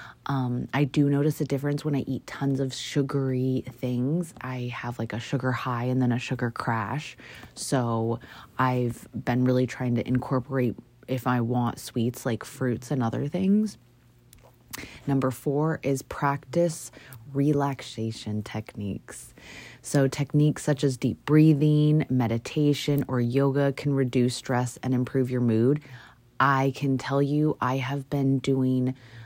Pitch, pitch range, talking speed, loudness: 130 Hz, 125-140 Hz, 145 wpm, -26 LUFS